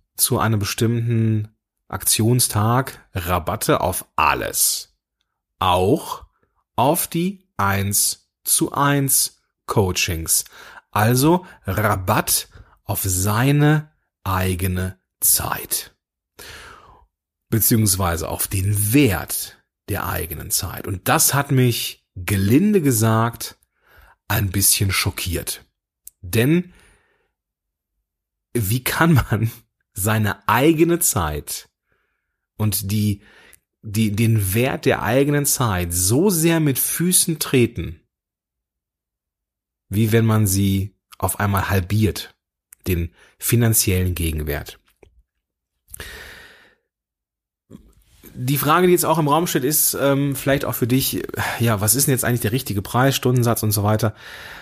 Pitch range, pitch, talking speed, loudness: 95-130 Hz, 110 Hz, 100 wpm, -19 LUFS